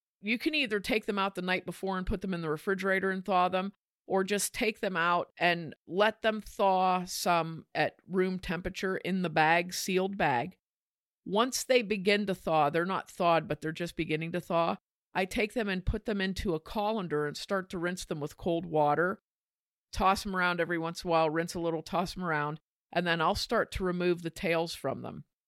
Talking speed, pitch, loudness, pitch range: 215 wpm, 180 Hz, -31 LUFS, 165-195 Hz